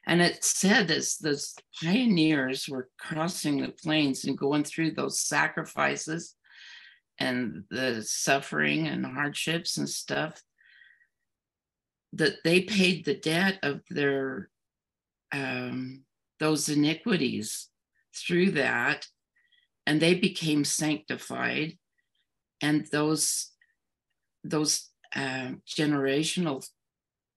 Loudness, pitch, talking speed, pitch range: -28 LUFS, 155 Hz, 95 wpm, 140-170 Hz